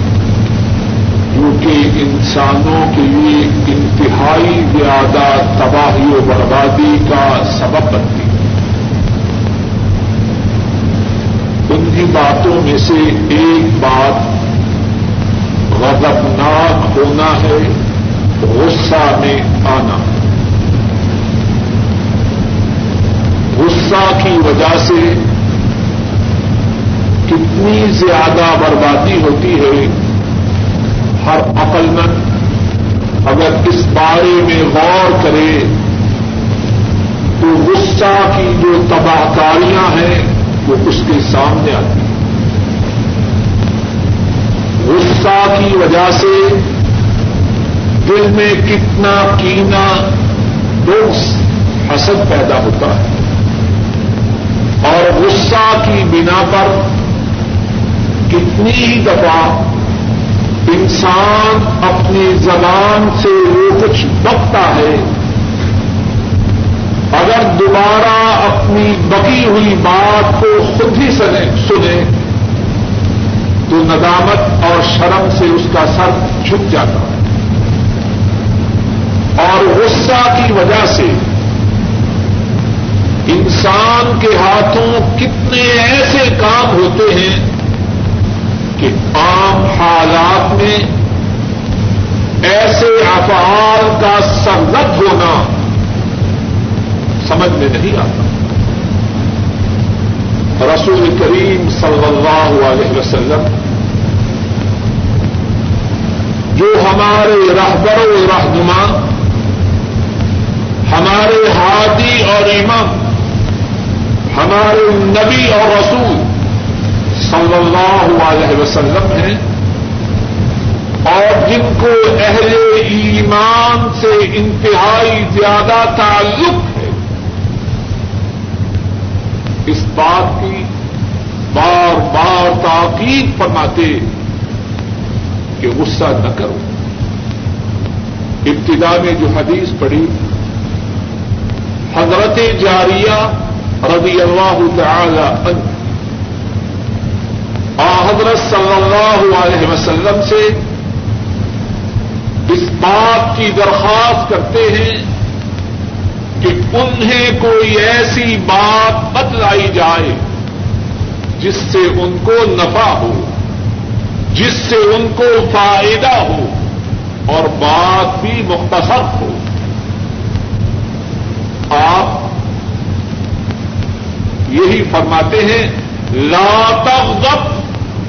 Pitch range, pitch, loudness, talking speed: 105-115 Hz, 110 Hz, -10 LUFS, 75 wpm